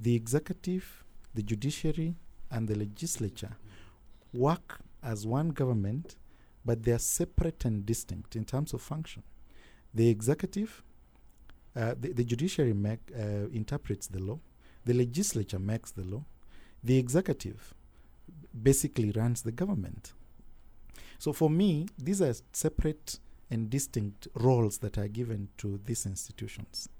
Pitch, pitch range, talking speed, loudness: 115 Hz, 105-145 Hz, 130 wpm, -32 LUFS